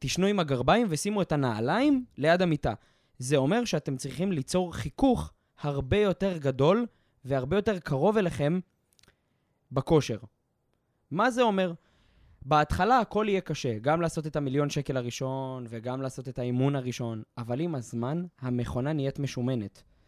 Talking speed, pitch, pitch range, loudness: 140 wpm, 145 Hz, 125-180 Hz, -28 LUFS